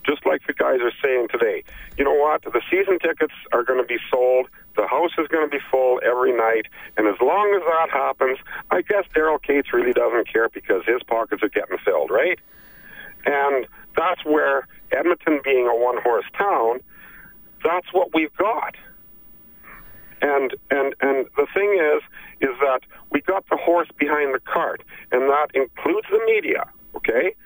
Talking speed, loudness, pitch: 175 wpm, -21 LUFS, 165 Hz